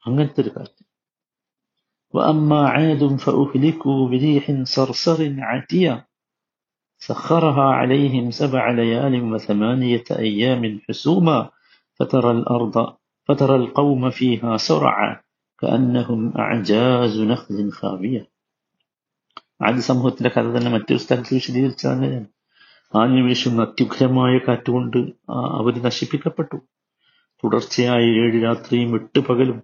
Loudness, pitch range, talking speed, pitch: -19 LUFS, 115-135 Hz, 80 wpm, 125 Hz